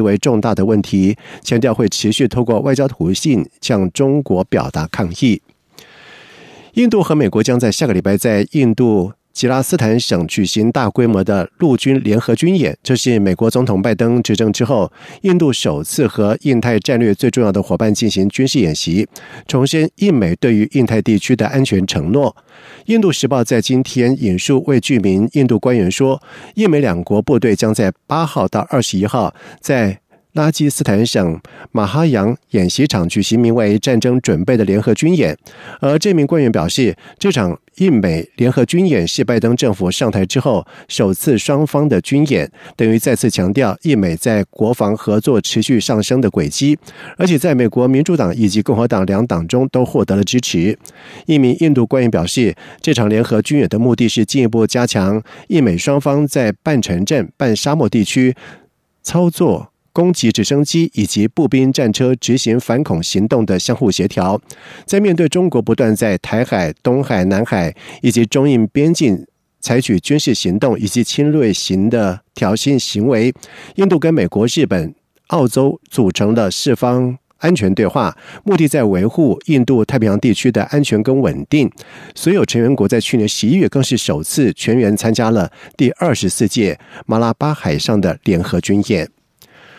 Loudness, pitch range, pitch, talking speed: -14 LUFS, 105-140 Hz, 120 Hz, 265 characters per minute